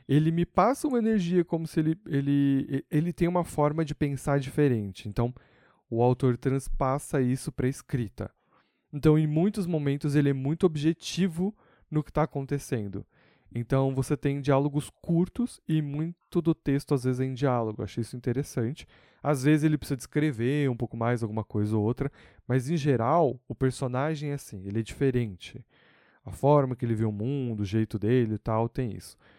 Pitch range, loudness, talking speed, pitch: 120-155 Hz, -28 LUFS, 185 wpm, 140 Hz